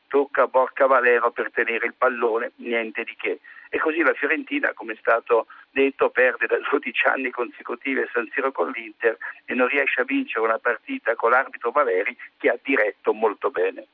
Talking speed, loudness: 185 wpm, -22 LUFS